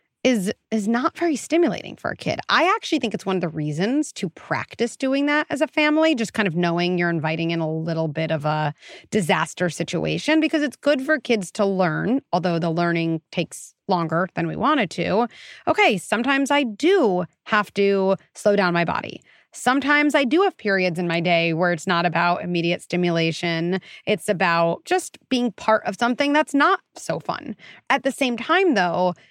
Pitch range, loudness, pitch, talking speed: 170-275 Hz, -21 LUFS, 200 Hz, 190 wpm